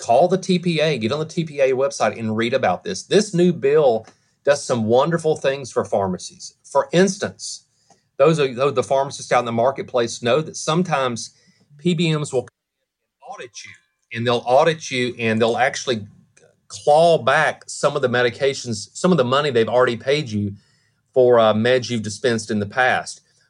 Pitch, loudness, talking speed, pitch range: 135 Hz, -19 LUFS, 170 wpm, 120-165 Hz